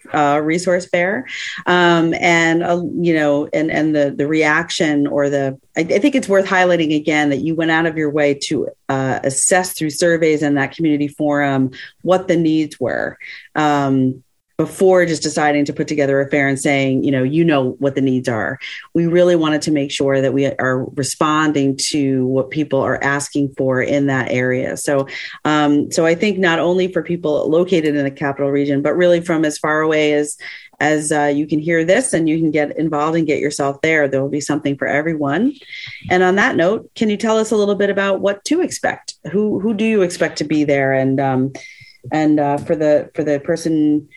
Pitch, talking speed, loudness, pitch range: 150 Hz, 210 wpm, -16 LUFS, 140-170 Hz